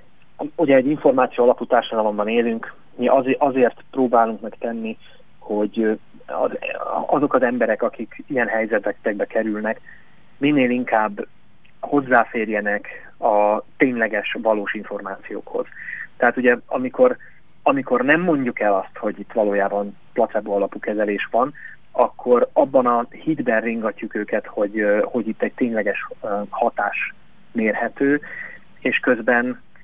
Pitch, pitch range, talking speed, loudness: 115 Hz, 105-130 Hz, 110 wpm, -21 LUFS